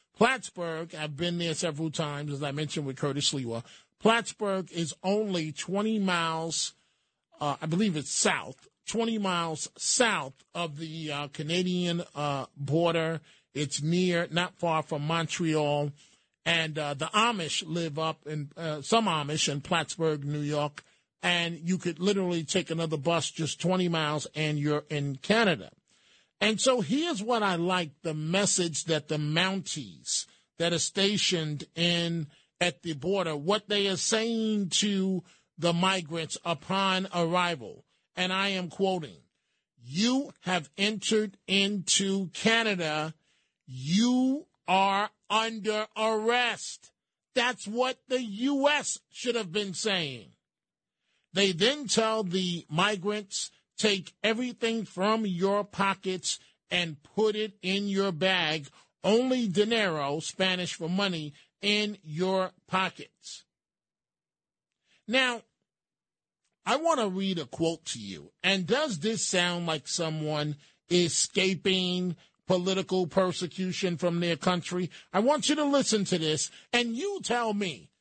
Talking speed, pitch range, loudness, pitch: 130 wpm, 160-205 Hz, -29 LUFS, 180 Hz